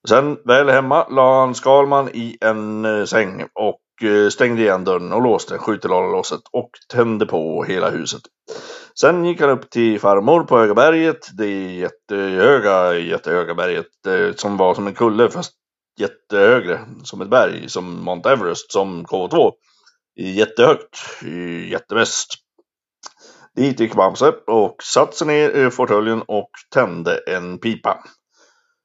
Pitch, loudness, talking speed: 125 Hz, -17 LUFS, 145 wpm